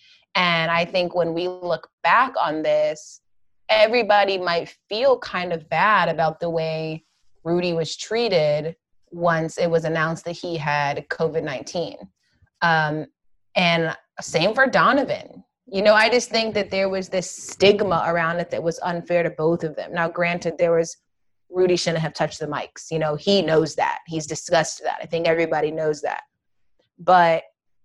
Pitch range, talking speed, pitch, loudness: 155-180 Hz, 170 wpm, 165 Hz, -21 LUFS